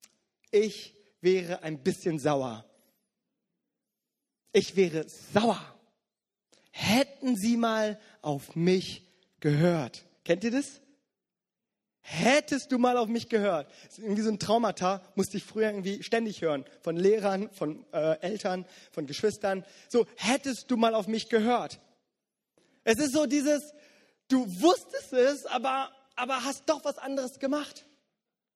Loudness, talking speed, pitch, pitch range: -29 LUFS, 130 wpm, 220 Hz, 185-255 Hz